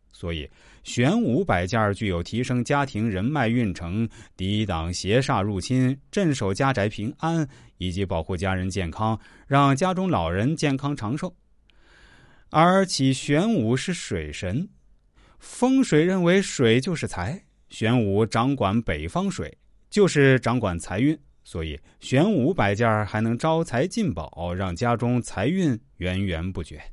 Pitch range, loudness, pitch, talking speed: 95-145 Hz, -24 LUFS, 115 Hz, 210 characters per minute